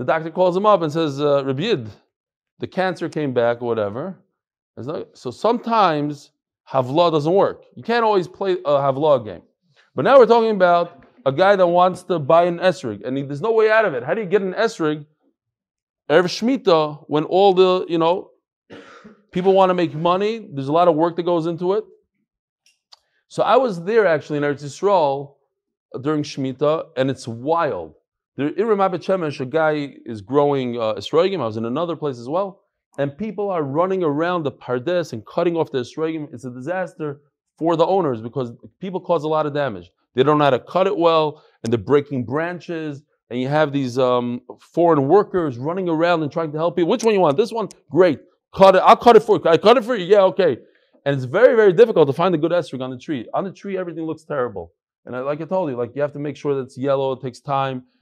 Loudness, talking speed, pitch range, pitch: -19 LUFS, 220 wpm, 140-185 Hz, 165 Hz